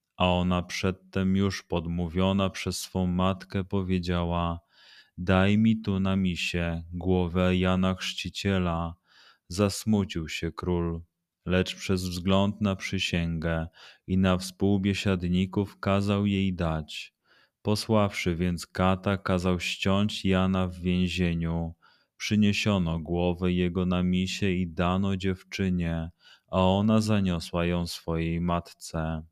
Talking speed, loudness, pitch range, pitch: 110 wpm, -27 LUFS, 85-95 Hz, 90 Hz